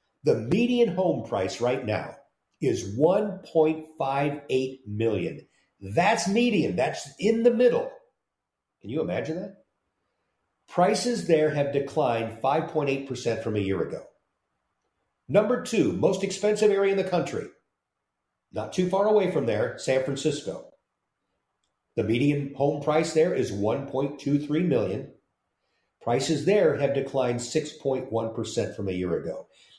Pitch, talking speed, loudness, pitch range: 145 Hz, 125 wpm, -26 LUFS, 130-190 Hz